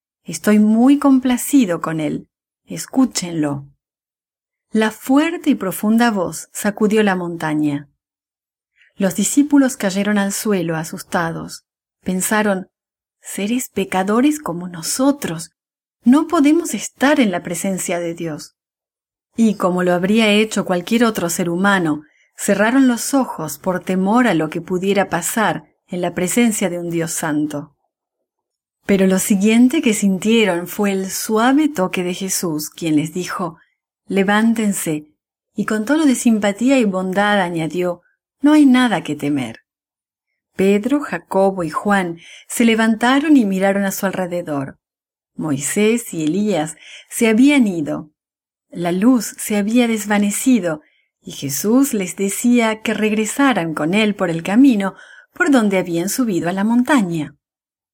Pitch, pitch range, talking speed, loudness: 195 Hz, 175-230 Hz, 130 wpm, -17 LUFS